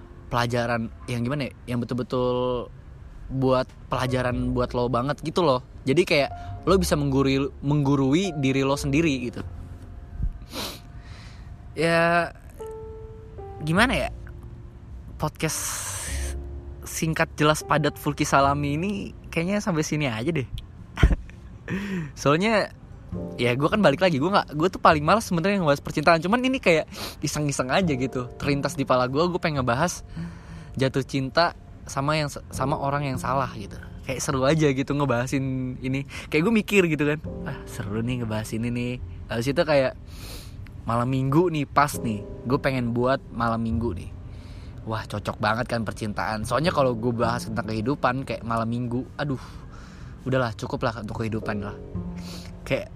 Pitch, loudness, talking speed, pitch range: 125 Hz, -25 LUFS, 145 wpm, 110-145 Hz